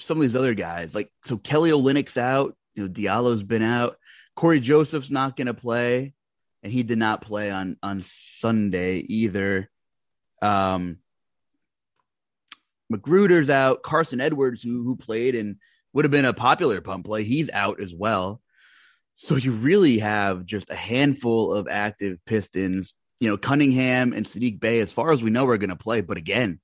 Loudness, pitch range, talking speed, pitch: -23 LUFS, 100-135 Hz, 170 wpm, 115 Hz